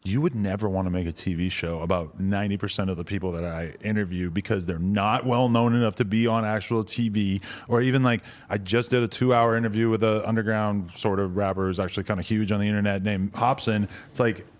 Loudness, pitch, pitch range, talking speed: -25 LUFS, 105 Hz, 95-115 Hz, 230 wpm